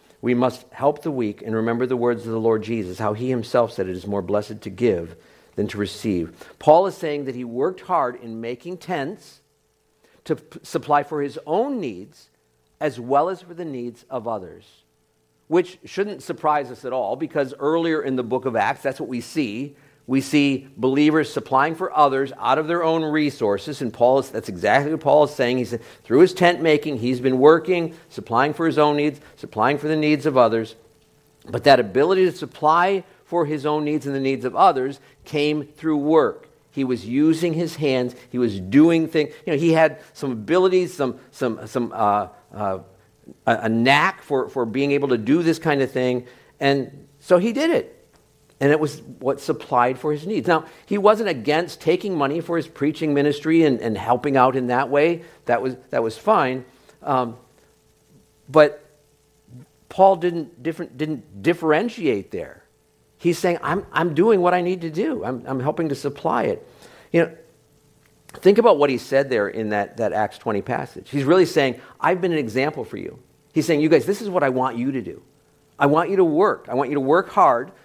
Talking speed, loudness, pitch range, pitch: 200 wpm, -21 LUFS, 125-160 Hz, 145 Hz